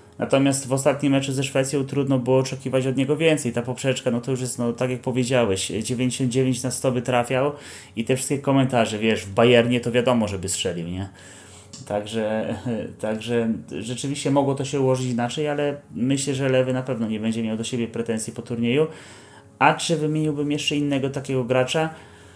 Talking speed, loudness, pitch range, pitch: 180 wpm, -23 LUFS, 115-140 Hz, 130 Hz